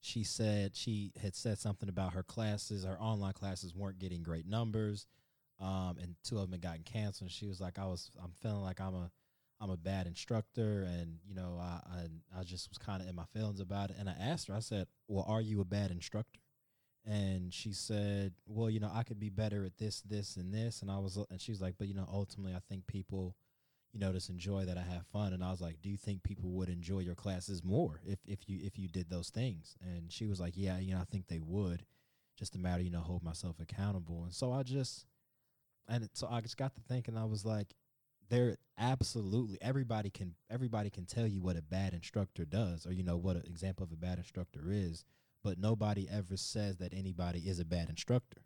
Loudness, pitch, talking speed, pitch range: -41 LUFS, 100 Hz, 235 wpm, 90-110 Hz